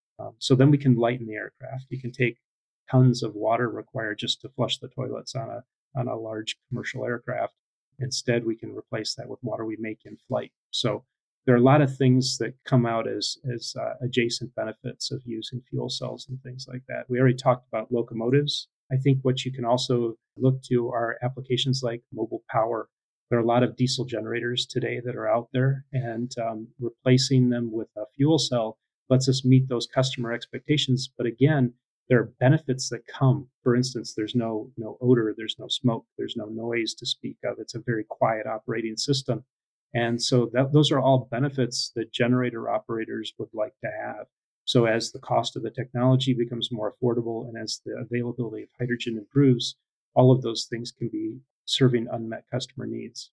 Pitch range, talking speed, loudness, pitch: 115-130 Hz, 195 wpm, -26 LUFS, 125 Hz